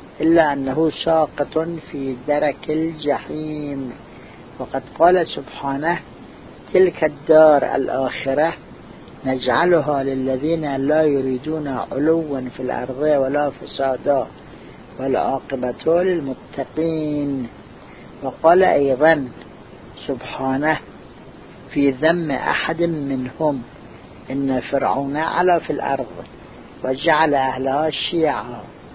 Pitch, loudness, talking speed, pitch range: 145 Hz, -20 LUFS, 80 wpm, 130-160 Hz